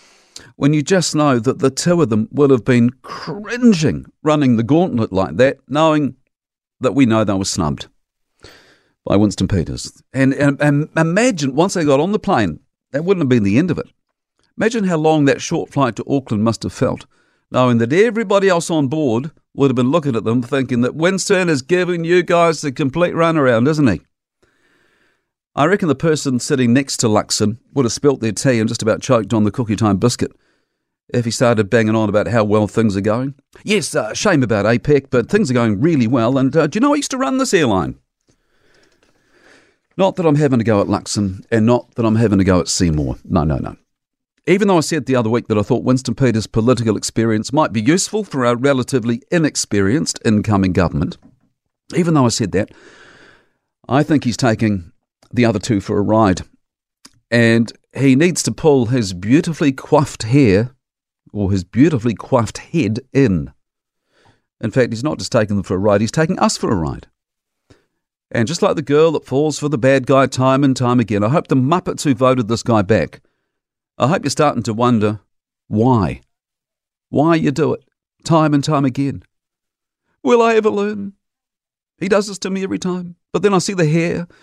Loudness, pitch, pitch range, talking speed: -16 LUFS, 130 Hz, 110-155 Hz, 200 wpm